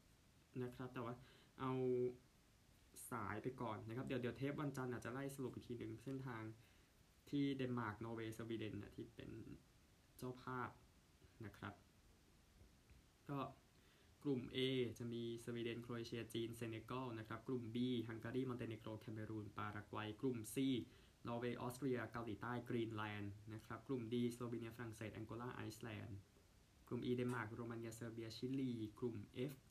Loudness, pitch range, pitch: -48 LUFS, 110-125 Hz, 115 Hz